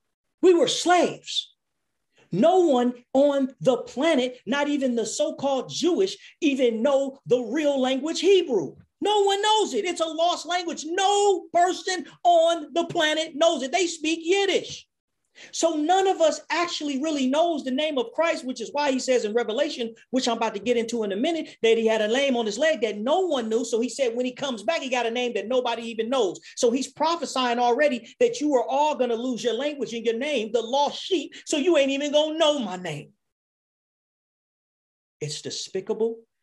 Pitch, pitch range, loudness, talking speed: 280 Hz, 240-330 Hz, -24 LUFS, 200 wpm